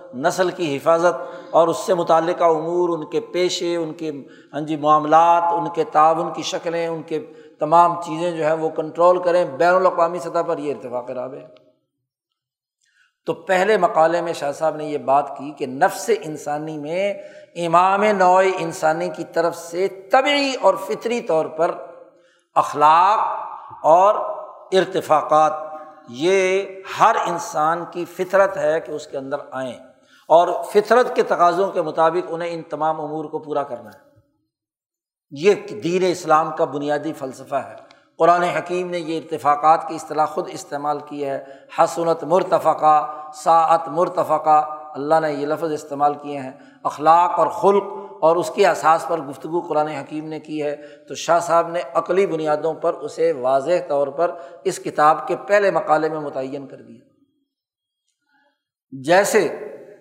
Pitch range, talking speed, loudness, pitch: 150-175 Hz, 155 wpm, -19 LUFS, 165 Hz